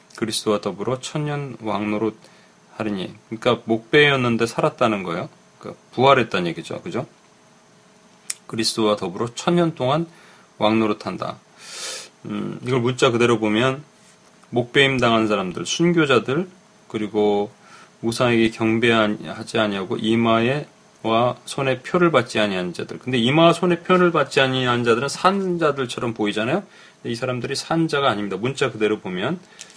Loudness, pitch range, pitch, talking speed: -21 LUFS, 110-165 Hz, 125 Hz, 325 characters per minute